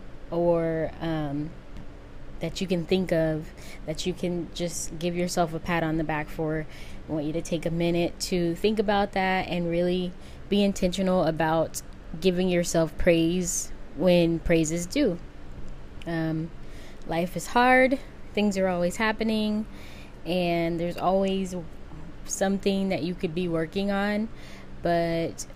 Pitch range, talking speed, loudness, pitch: 160-185 Hz, 145 wpm, -26 LUFS, 170 Hz